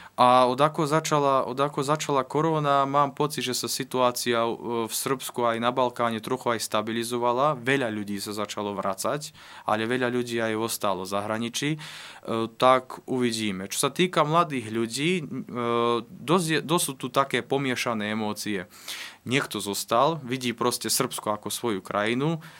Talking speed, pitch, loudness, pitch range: 145 wpm, 125 Hz, -26 LUFS, 115-140 Hz